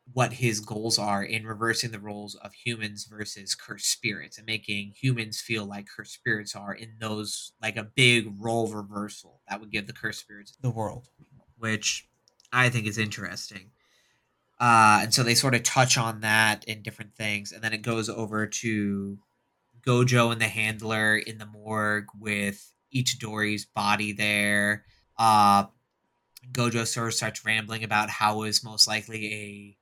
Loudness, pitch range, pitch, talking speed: -26 LUFS, 105-115 Hz, 110 Hz, 165 wpm